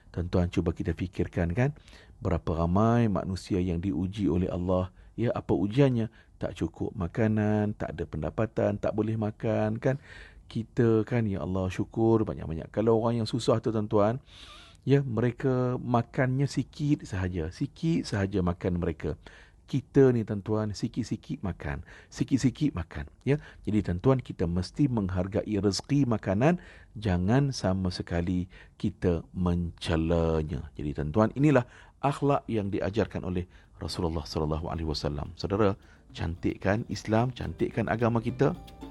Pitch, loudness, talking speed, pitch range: 100 Hz, -29 LUFS, 130 wpm, 90-115 Hz